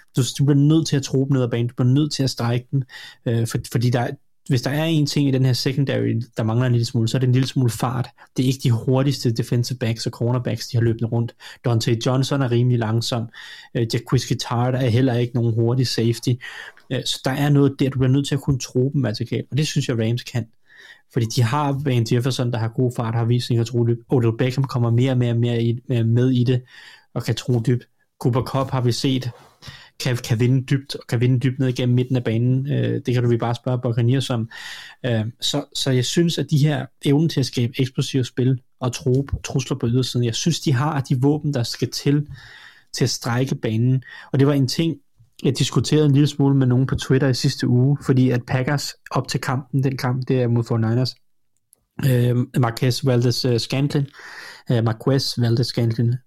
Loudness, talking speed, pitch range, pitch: -21 LUFS, 235 wpm, 120-135 Hz, 130 Hz